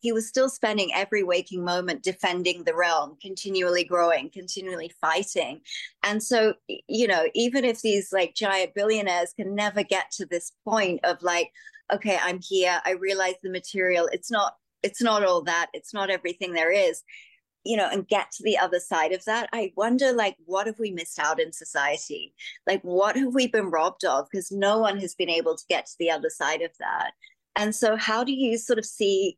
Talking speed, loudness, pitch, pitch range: 200 wpm, -25 LUFS, 195 Hz, 180-215 Hz